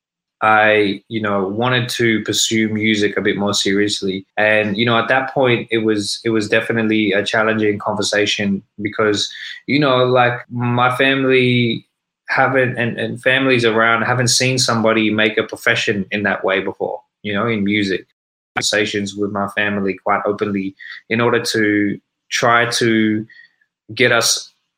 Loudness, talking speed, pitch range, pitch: -16 LUFS, 155 wpm, 105-120 Hz, 110 Hz